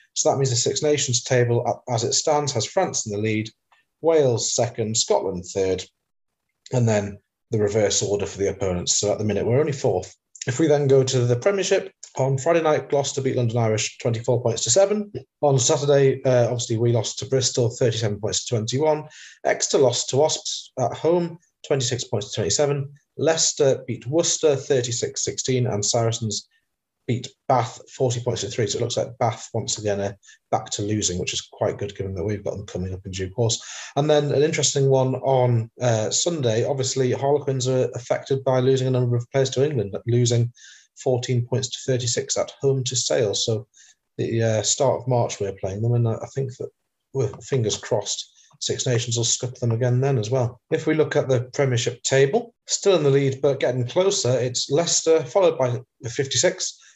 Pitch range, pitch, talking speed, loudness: 115-140 Hz, 125 Hz, 195 wpm, -22 LUFS